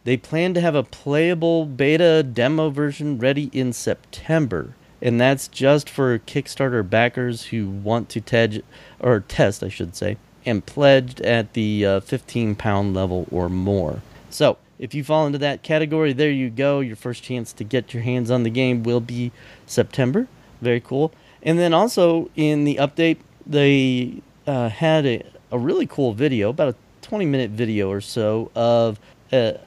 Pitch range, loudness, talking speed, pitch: 115-145 Hz, -21 LUFS, 170 wpm, 130 Hz